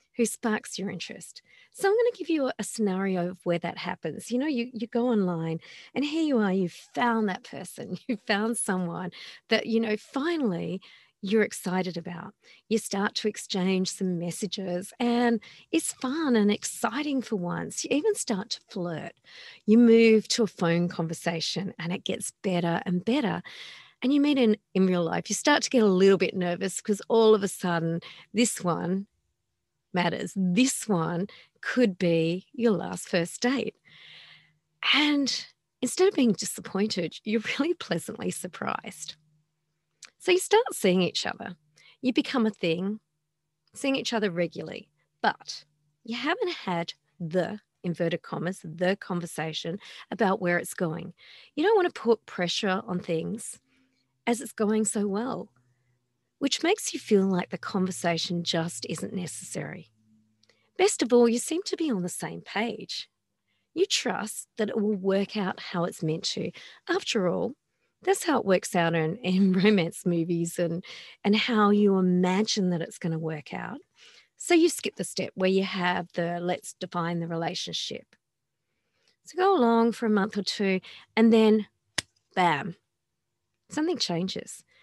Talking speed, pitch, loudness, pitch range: 165 wpm, 195 Hz, -27 LUFS, 175-235 Hz